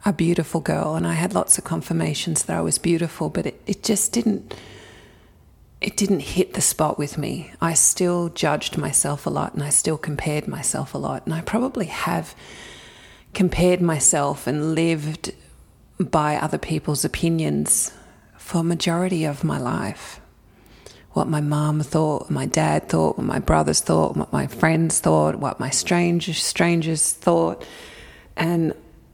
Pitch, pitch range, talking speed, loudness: 160 Hz, 145-170 Hz, 160 wpm, -21 LUFS